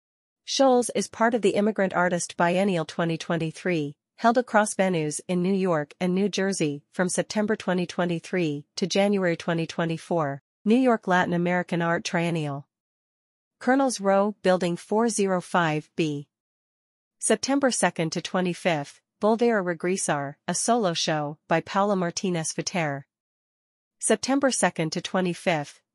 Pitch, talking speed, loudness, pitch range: 180 Hz, 115 wpm, -25 LUFS, 165-205 Hz